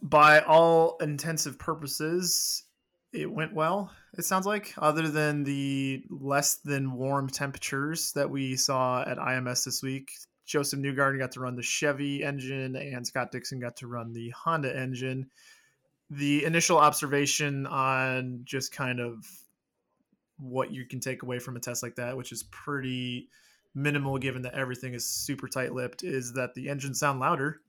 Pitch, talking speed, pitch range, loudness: 135 Hz, 165 wpm, 130-150 Hz, -28 LUFS